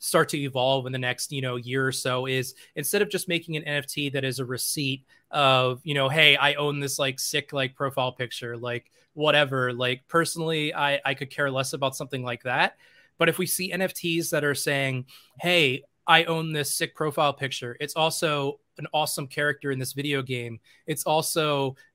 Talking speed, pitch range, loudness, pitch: 200 wpm, 130-155 Hz, -25 LUFS, 140 Hz